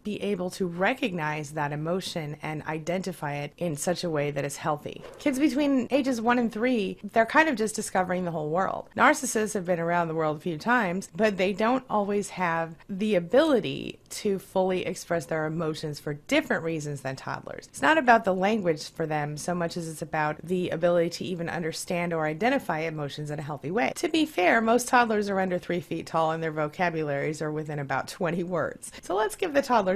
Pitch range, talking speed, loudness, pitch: 155-215 Hz, 205 wpm, -27 LUFS, 175 Hz